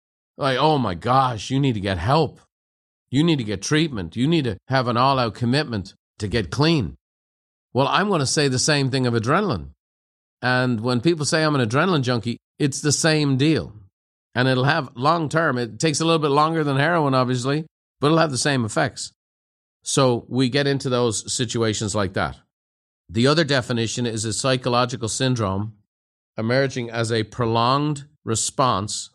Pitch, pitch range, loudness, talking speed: 125 Hz, 105-145 Hz, -21 LUFS, 175 wpm